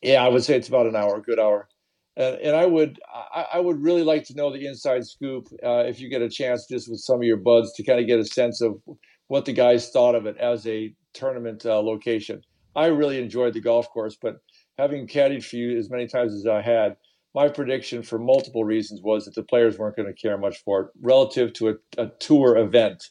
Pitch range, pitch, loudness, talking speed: 110-130 Hz, 120 Hz, -22 LUFS, 245 wpm